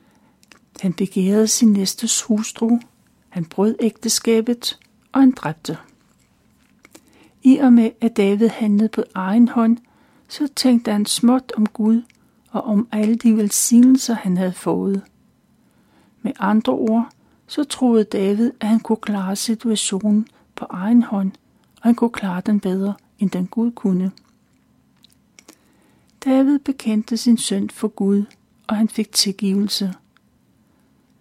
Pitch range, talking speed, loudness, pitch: 205-235 Hz, 130 wpm, -18 LUFS, 220 Hz